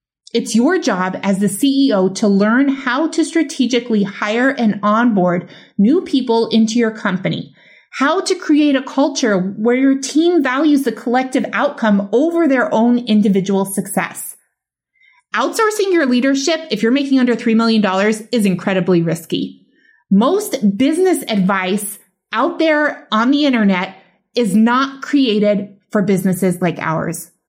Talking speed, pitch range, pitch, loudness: 140 wpm, 200-275 Hz, 230 Hz, -15 LUFS